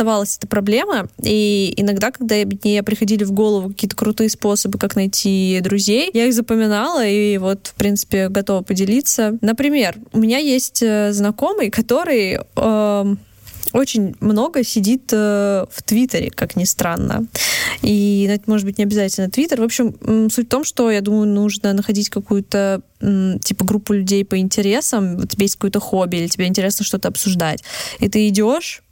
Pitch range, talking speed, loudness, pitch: 200-225 Hz, 155 wpm, -17 LUFS, 210 Hz